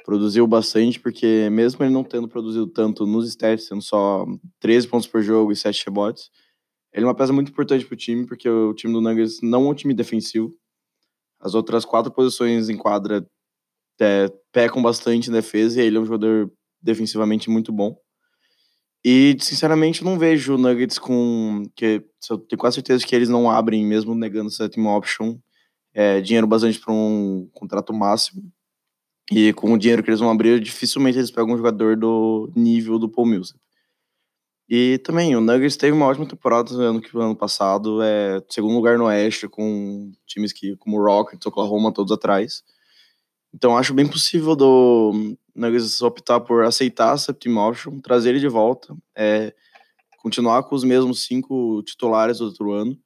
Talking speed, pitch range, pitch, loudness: 175 wpm, 110-125 Hz, 115 Hz, -19 LUFS